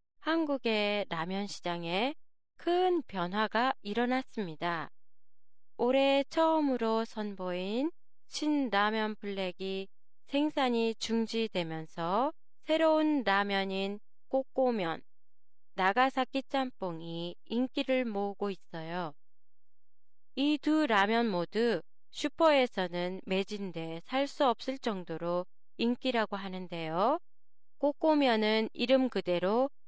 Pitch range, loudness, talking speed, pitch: 190-265 Hz, -32 LUFS, 210 characters per minute, 225 Hz